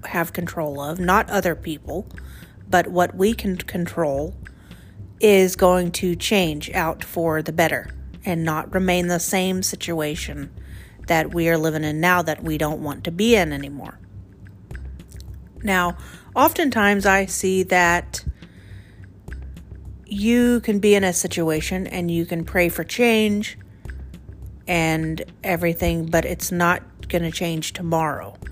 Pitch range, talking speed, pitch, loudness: 155-185 Hz, 135 wpm, 170 Hz, -21 LUFS